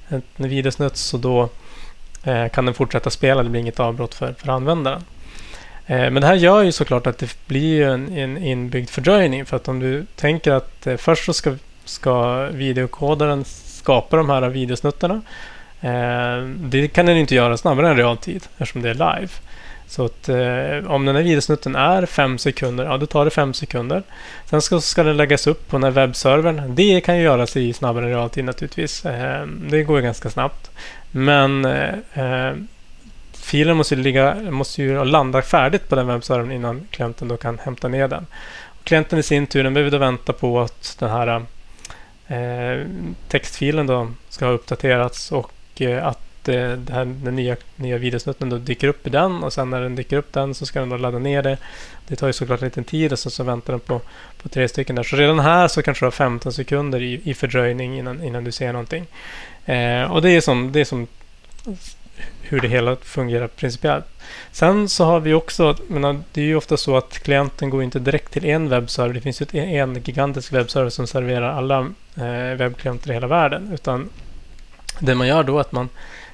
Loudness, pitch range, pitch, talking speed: -19 LUFS, 125-150 Hz, 135 Hz, 200 wpm